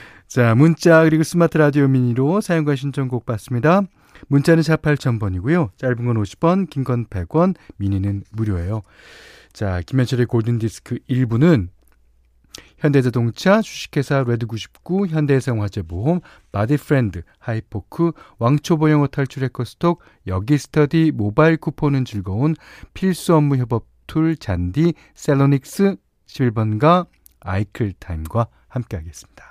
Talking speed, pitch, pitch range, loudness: 285 characters per minute, 130 Hz, 110-155 Hz, -19 LUFS